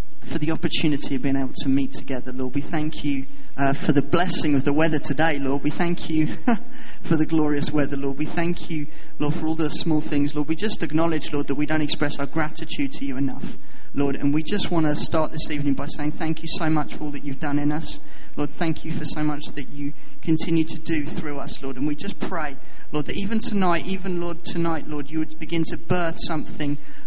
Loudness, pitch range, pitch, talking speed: -25 LUFS, 145-165 Hz, 155 Hz, 240 wpm